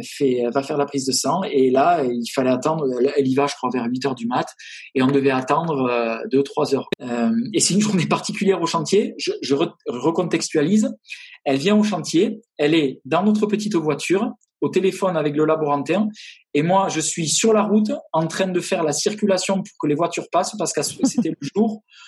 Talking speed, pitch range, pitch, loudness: 210 wpm, 140-200 Hz, 160 Hz, -20 LUFS